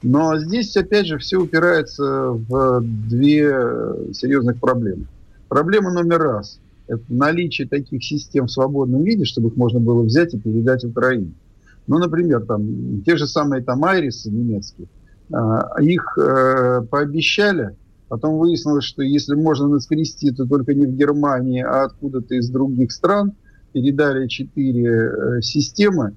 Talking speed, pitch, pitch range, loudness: 130 wpm, 135 Hz, 120-150 Hz, -18 LUFS